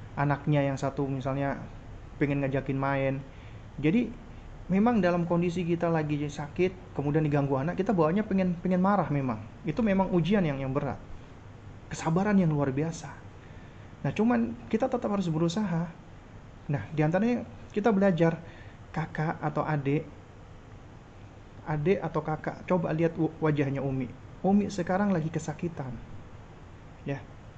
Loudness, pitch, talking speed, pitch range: -29 LUFS, 150 Hz, 125 wpm, 120-175 Hz